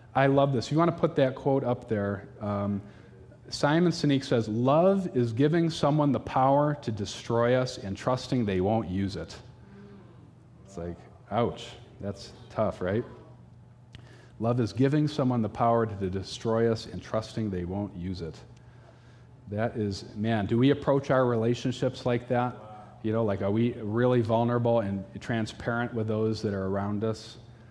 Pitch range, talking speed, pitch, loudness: 105-125 Hz, 165 wpm, 120 Hz, -28 LUFS